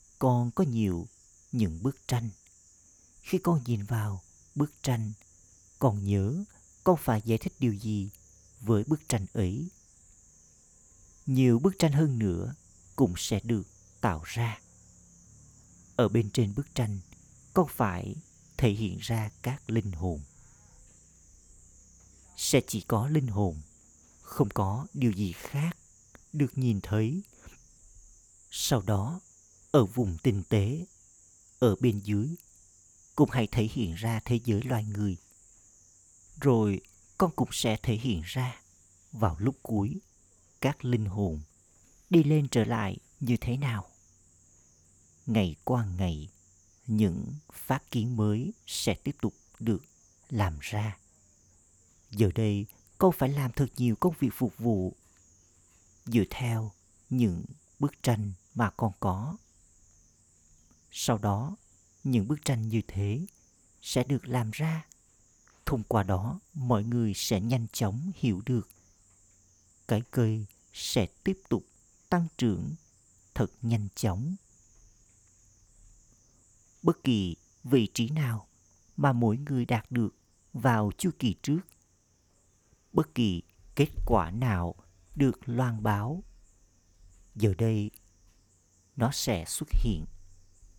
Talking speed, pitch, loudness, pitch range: 125 wpm, 105 Hz, -30 LUFS, 90-120 Hz